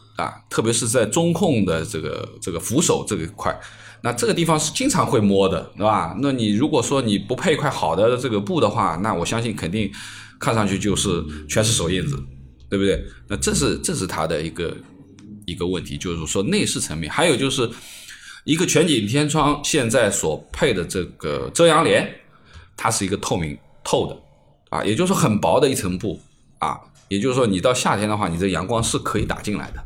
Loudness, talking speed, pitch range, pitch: -21 LUFS, 295 characters per minute, 90-120 Hz, 105 Hz